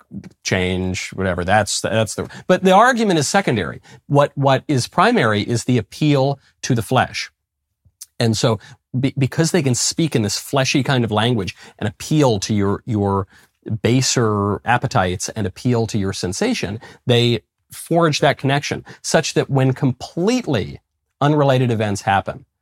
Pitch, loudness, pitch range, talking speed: 120 Hz, -18 LUFS, 100-140 Hz, 150 wpm